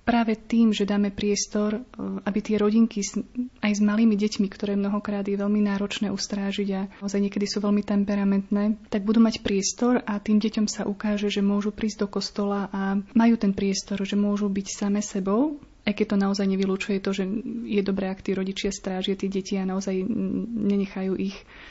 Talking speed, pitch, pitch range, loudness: 180 wpm, 205 Hz, 200-215 Hz, -25 LUFS